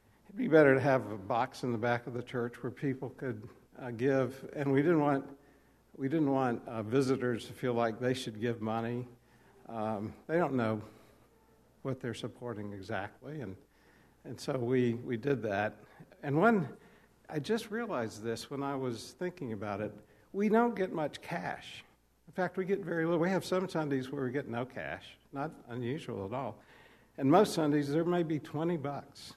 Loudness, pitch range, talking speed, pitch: -33 LUFS, 115-150 Hz, 190 wpm, 130 Hz